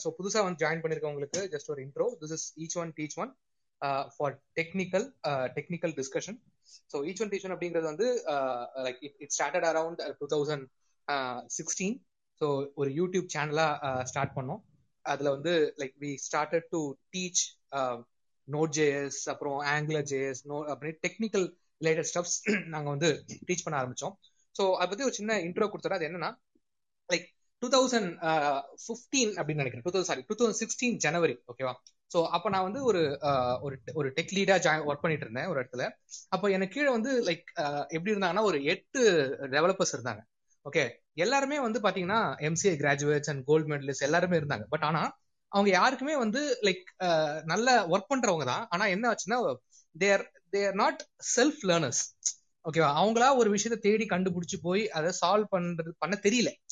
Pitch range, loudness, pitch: 145-200 Hz, -30 LUFS, 170 Hz